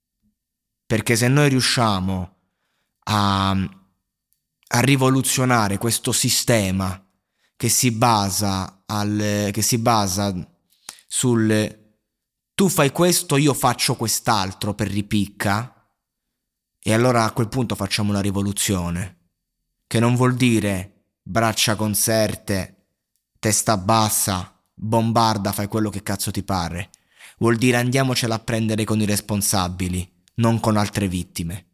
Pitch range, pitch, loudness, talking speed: 95-115 Hz, 105 Hz, -20 LUFS, 115 wpm